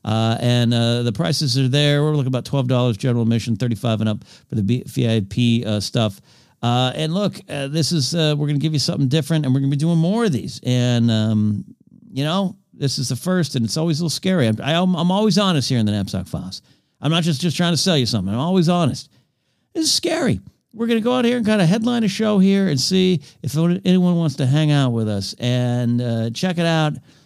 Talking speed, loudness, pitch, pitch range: 245 wpm, -19 LUFS, 140 Hz, 120-170 Hz